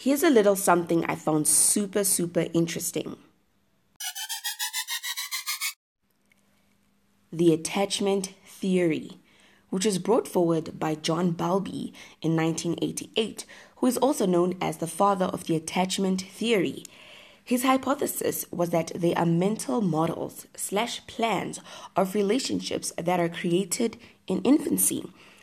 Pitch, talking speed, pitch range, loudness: 190 Hz, 115 wpm, 170-220 Hz, -26 LUFS